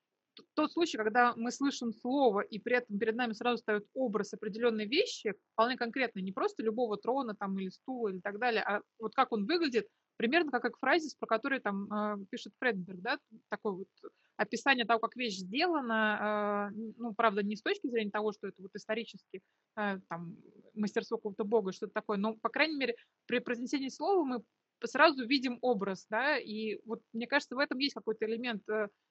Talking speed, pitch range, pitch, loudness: 180 wpm, 210-260 Hz, 230 Hz, -33 LUFS